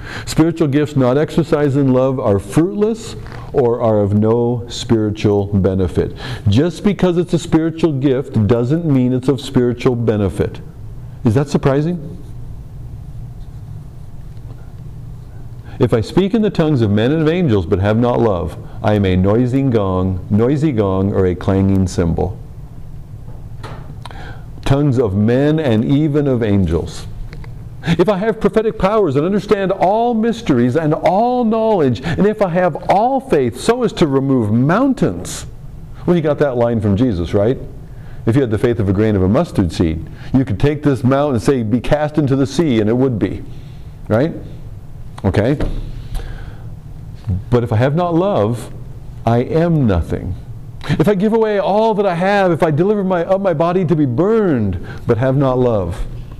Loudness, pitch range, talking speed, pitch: -15 LUFS, 115-155 Hz, 165 wpm, 130 Hz